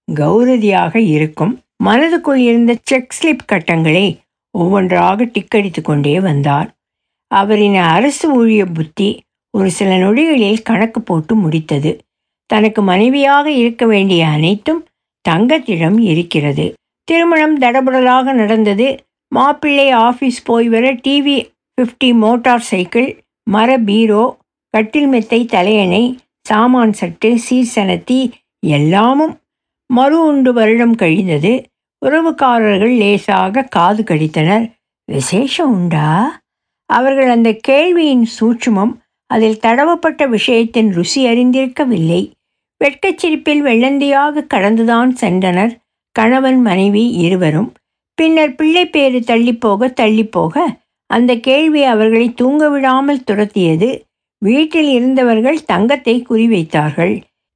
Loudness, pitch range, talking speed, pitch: -12 LUFS, 200-265 Hz, 90 wpm, 230 Hz